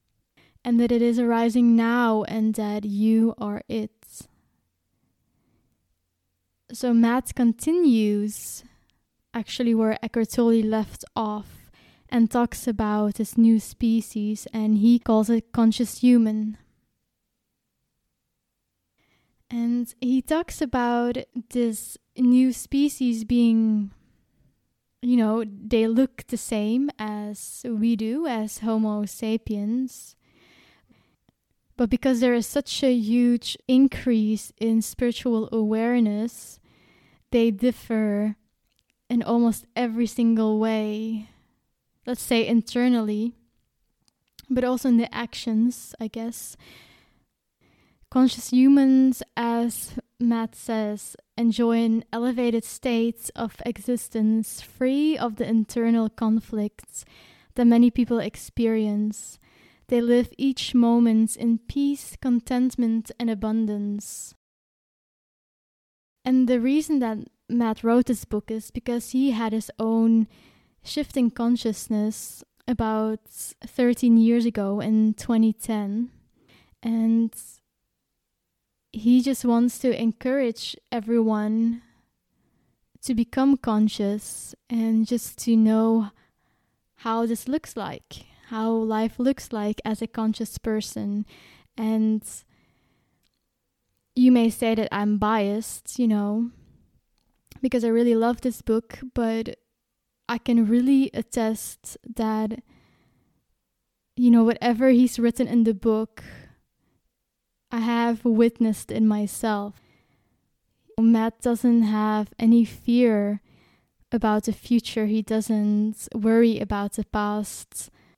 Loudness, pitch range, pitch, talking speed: -23 LUFS, 220-240 Hz, 230 Hz, 105 wpm